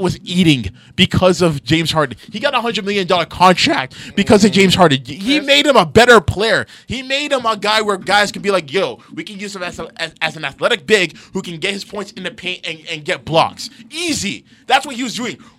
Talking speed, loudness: 240 wpm, -15 LUFS